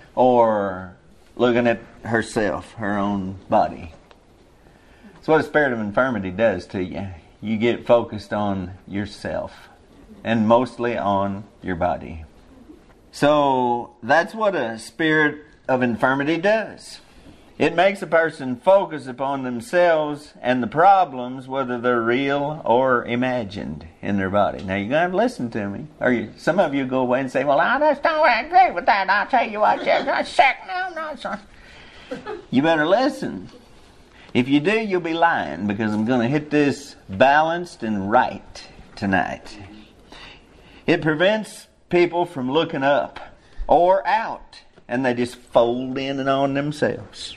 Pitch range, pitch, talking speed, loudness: 110-160 Hz, 125 Hz, 155 wpm, -20 LUFS